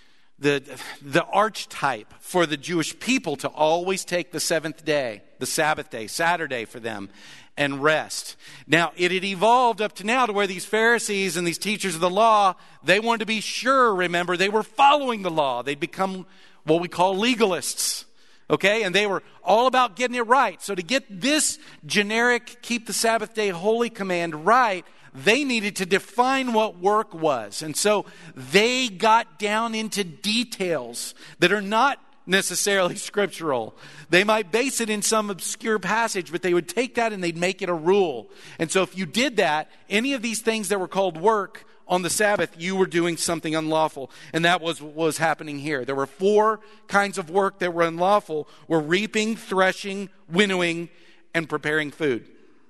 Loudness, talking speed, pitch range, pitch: -23 LUFS, 180 wpm, 165-220 Hz, 190 Hz